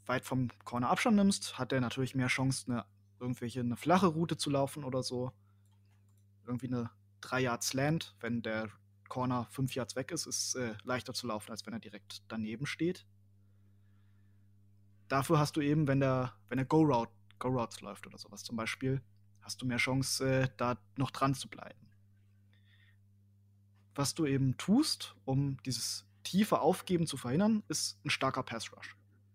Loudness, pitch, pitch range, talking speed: -34 LUFS, 120 Hz, 100-135 Hz, 165 wpm